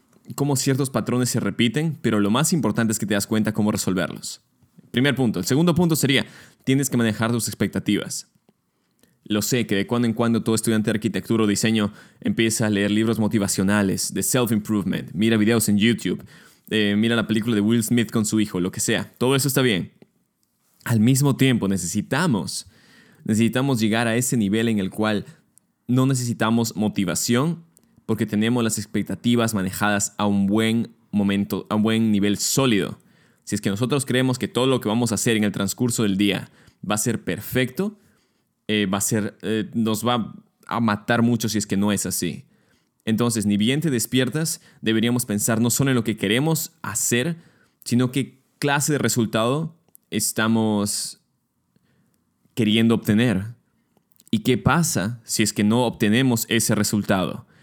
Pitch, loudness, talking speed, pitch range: 115 Hz, -22 LUFS, 175 wpm, 105-125 Hz